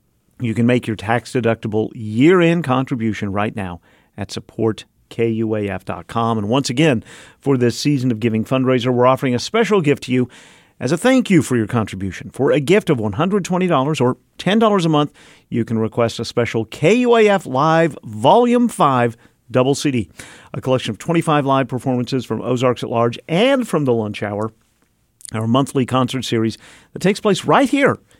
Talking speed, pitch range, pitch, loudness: 170 wpm, 115-155 Hz, 125 Hz, -17 LUFS